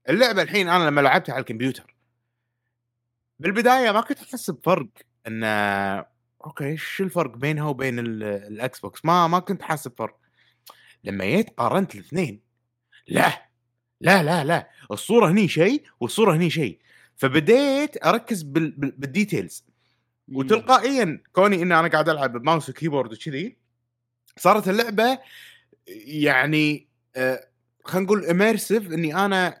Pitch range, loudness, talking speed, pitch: 120-195 Hz, -22 LUFS, 120 wpm, 155 Hz